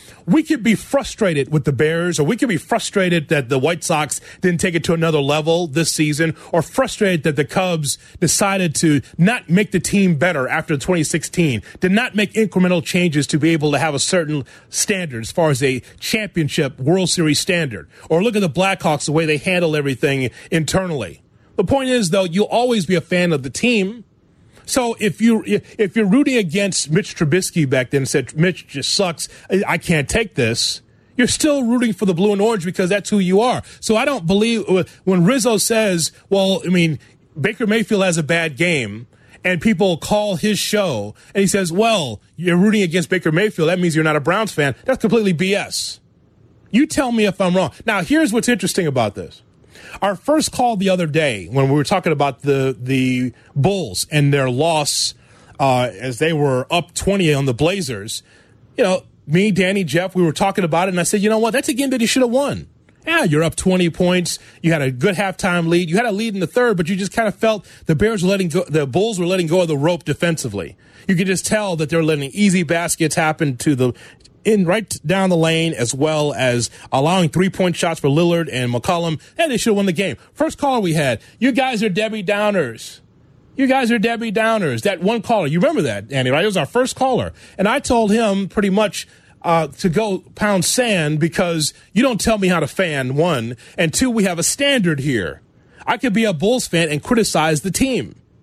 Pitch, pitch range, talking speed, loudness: 180 Hz, 155-210 Hz, 215 wpm, -17 LUFS